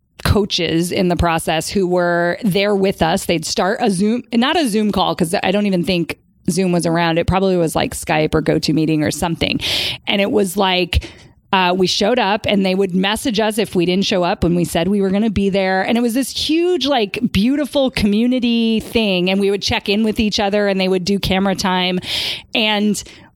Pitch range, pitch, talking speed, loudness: 175-210 Hz, 195 Hz, 225 wpm, -16 LUFS